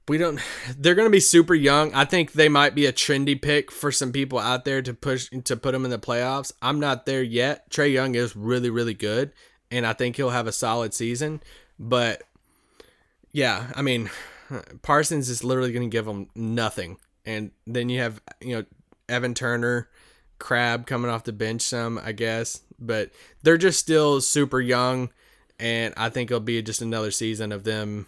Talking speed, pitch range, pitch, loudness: 195 wpm, 115-140 Hz, 125 Hz, -23 LUFS